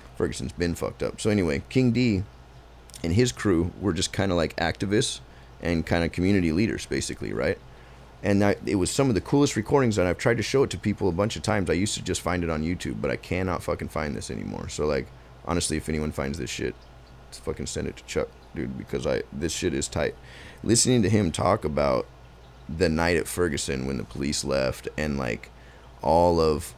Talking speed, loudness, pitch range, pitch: 220 wpm, -26 LUFS, 70-105 Hz, 85 Hz